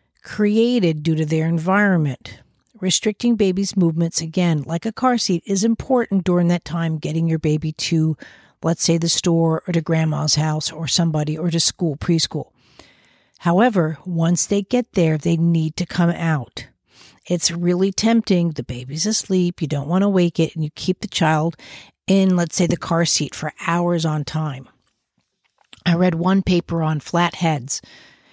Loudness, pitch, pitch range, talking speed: -19 LUFS, 170 Hz, 160-185 Hz, 170 wpm